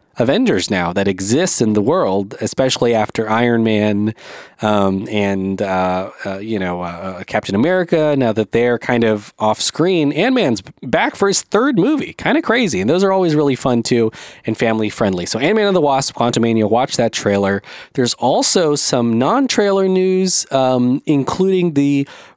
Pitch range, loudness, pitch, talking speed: 105-150 Hz, -16 LUFS, 115 Hz, 170 wpm